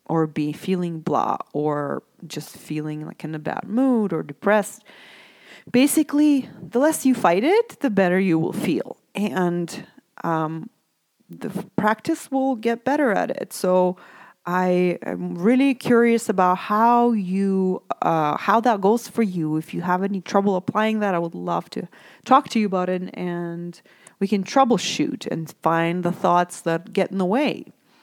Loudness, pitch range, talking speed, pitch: -22 LUFS, 175-235 Hz, 165 wpm, 195 Hz